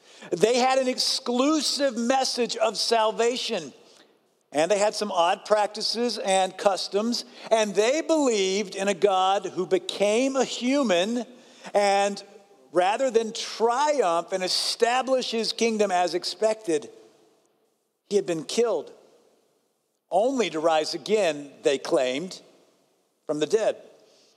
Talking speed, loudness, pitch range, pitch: 120 wpm, -24 LUFS, 190-255 Hz, 215 Hz